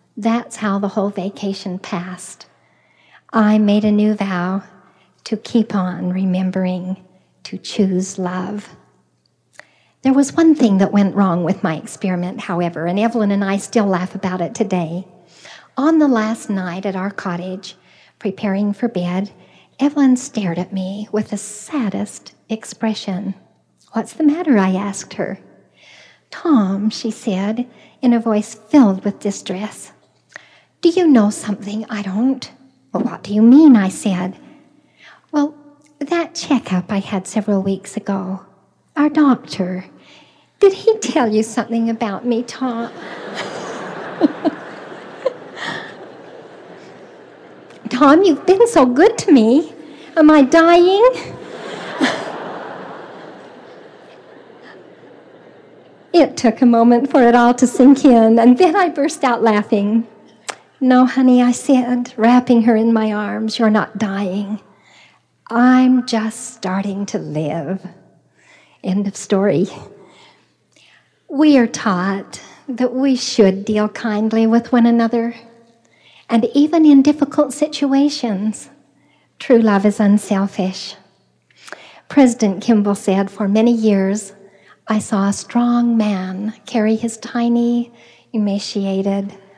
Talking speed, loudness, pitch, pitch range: 120 wpm, -16 LUFS, 215 Hz, 195-250 Hz